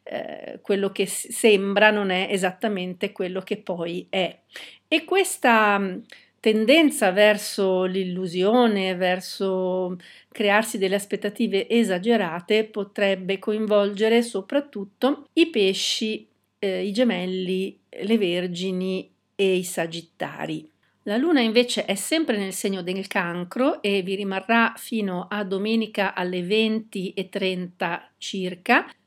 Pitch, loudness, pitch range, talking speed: 200 Hz, -23 LUFS, 185-225 Hz, 105 wpm